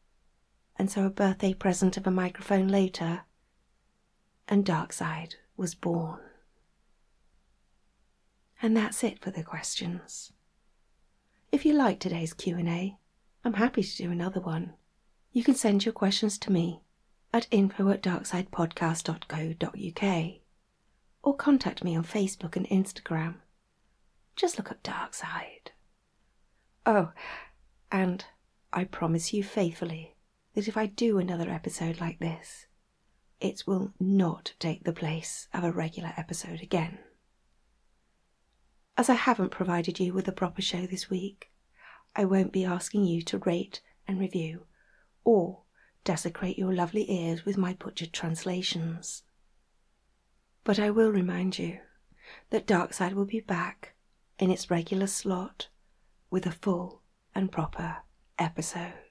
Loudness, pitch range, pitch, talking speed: -30 LUFS, 170-200 Hz, 185 Hz, 130 wpm